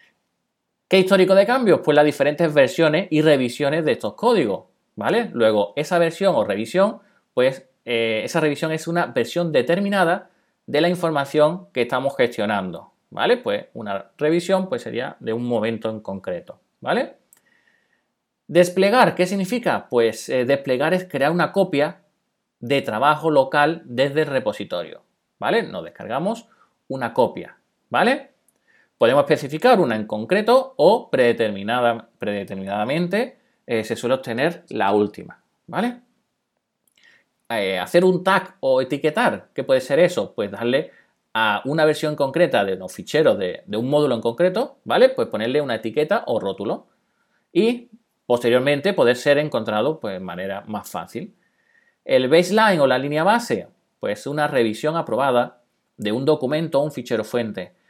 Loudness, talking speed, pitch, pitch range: -20 LUFS, 145 wpm, 150 Hz, 125-185 Hz